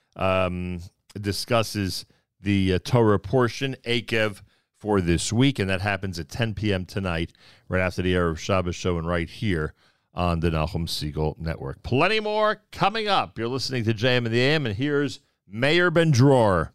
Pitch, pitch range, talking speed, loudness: 100 Hz, 90-130 Hz, 170 wpm, -24 LUFS